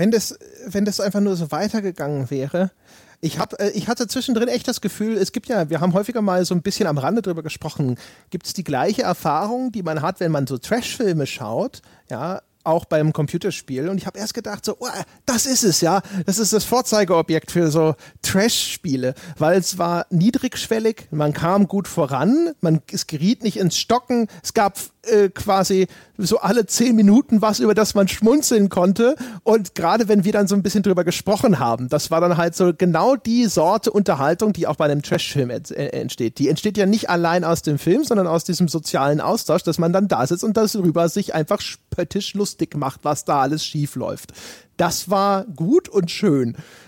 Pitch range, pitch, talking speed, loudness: 160-215 Hz, 190 Hz, 200 wpm, -20 LUFS